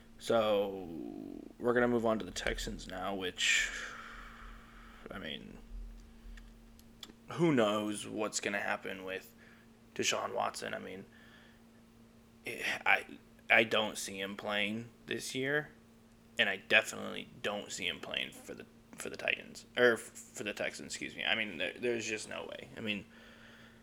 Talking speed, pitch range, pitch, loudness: 145 wpm, 105-115 Hz, 115 Hz, -34 LUFS